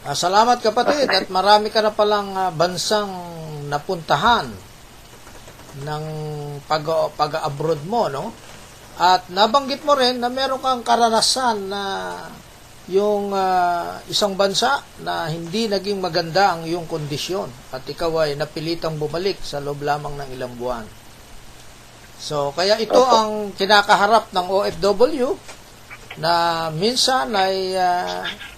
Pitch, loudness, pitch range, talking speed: 180 Hz, -19 LUFS, 150-210 Hz, 120 wpm